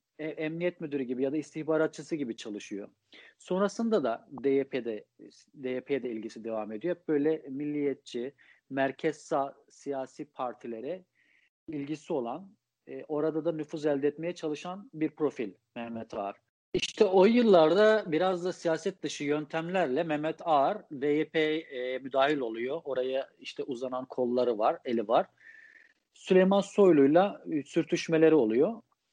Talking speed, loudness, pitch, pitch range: 115 wpm, -29 LUFS, 155 Hz, 135-175 Hz